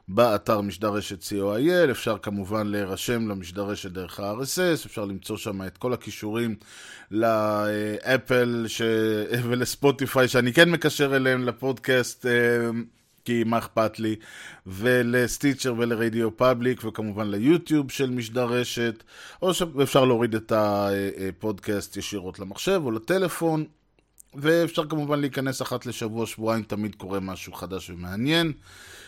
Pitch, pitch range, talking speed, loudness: 115 Hz, 105-130 Hz, 110 wpm, -25 LUFS